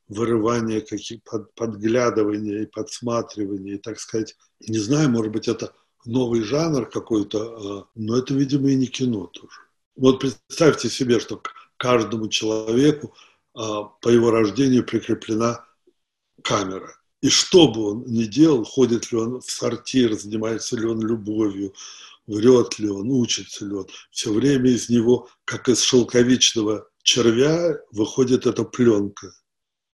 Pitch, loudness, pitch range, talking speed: 115 Hz, -21 LUFS, 110-125 Hz, 135 wpm